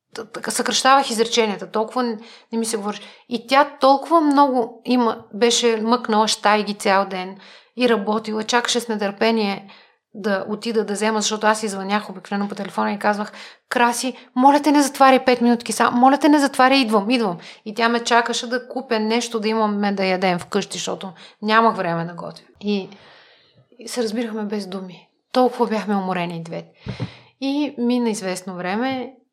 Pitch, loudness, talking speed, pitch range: 225 Hz, -19 LUFS, 165 wpm, 205-245 Hz